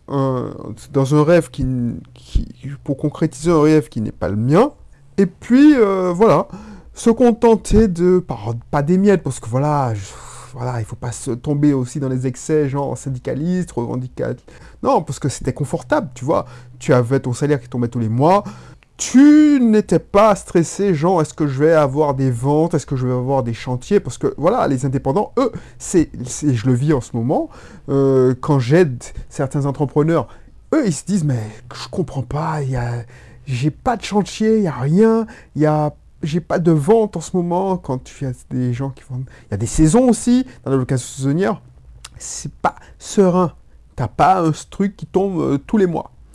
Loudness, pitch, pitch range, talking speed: -17 LUFS, 145 Hz, 125-180 Hz, 200 wpm